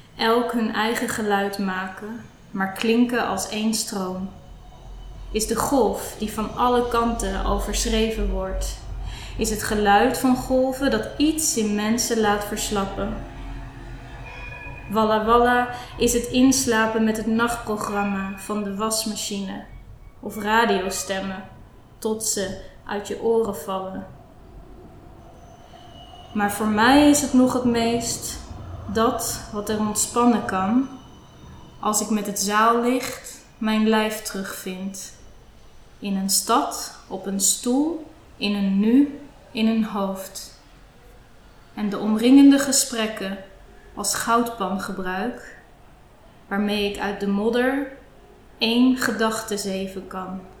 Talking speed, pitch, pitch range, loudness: 115 wpm, 220 Hz, 200-235 Hz, -22 LUFS